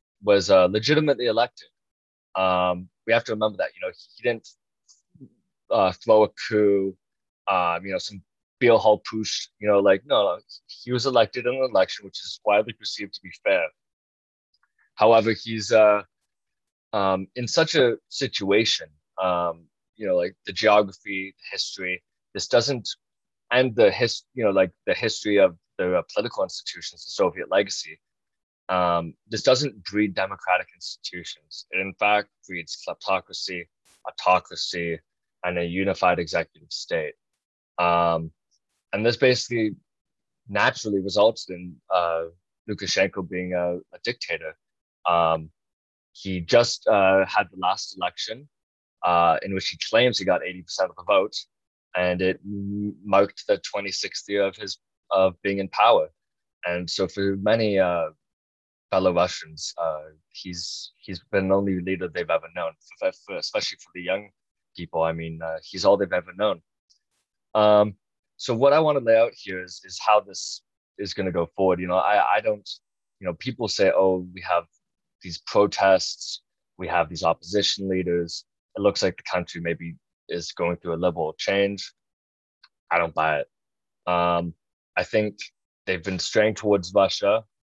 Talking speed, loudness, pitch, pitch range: 160 wpm, -24 LUFS, 95 Hz, 85-105 Hz